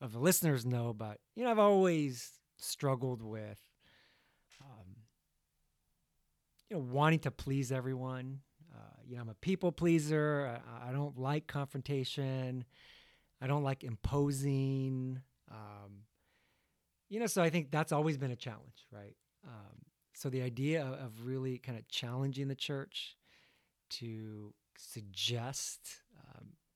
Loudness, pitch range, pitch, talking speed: -36 LUFS, 120-145 Hz, 135 Hz, 130 wpm